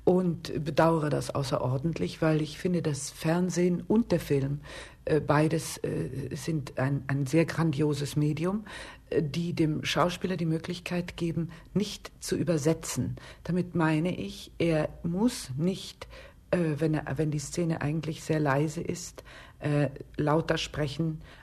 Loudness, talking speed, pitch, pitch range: -29 LUFS, 140 wpm, 160 Hz, 150-170 Hz